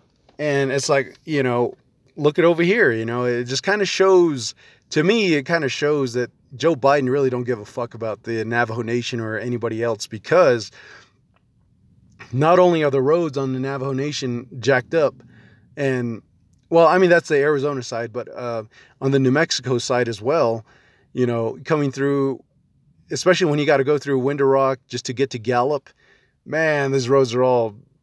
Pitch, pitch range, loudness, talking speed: 135 Hz, 120-145 Hz, -20 LUFS, 190 wpm